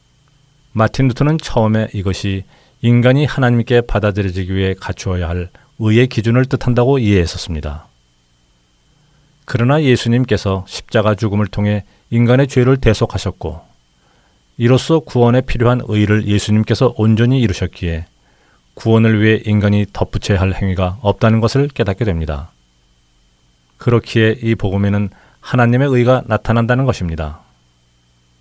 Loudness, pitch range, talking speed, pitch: -15 LUFS, 95-120 Hz, 315 characters per minute, 110 Hz